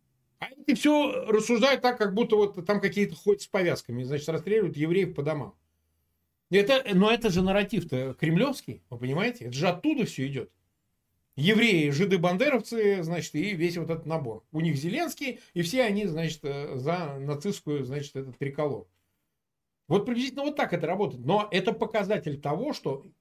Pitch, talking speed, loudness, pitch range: 175 Hz, 160 wpm, -27 LUFS, 145-215 Hz